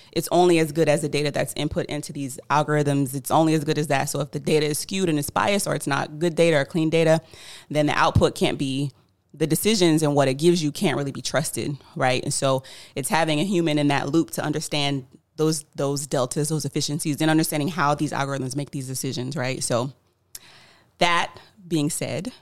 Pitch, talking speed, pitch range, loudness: 150 Hz, 215 wpm, 140-160 Hz, -23 LUFS